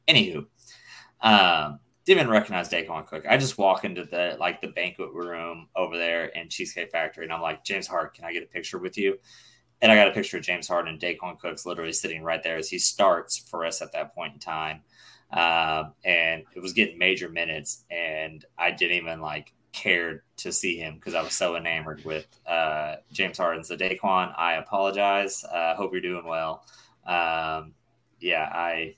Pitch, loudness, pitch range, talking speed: 85 Hz, -25 LUFS, 80-90 Hz, 200 wpm